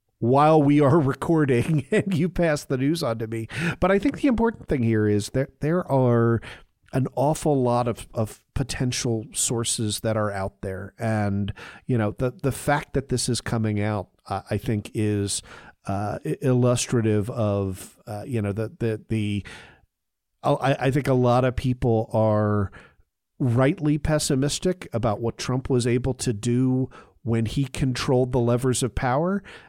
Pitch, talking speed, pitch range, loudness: 120 Hz, 165 wpm, 110-140 Hz, -24 LUFS